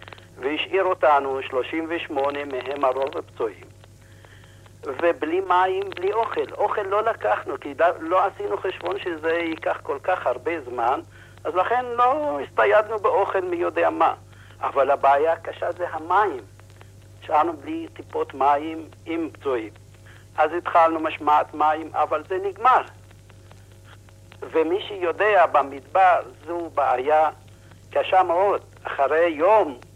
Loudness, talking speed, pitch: -22 LUFS, 115 wpm, 160 Hz